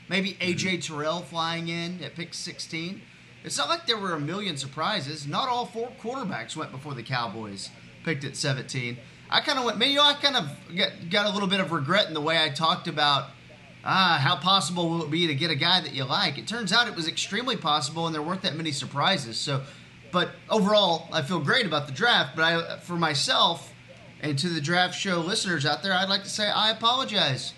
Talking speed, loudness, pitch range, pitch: 220 wpm, -25 LUFS, 150-195 Hz, 165 Hz